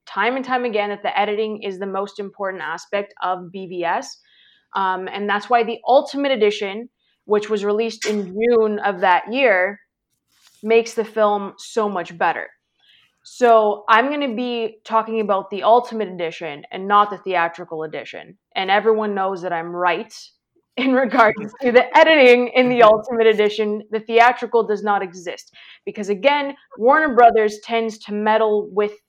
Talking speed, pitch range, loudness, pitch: 160 wpm, 200-230 Hz, -18 LUFS, 215 Hz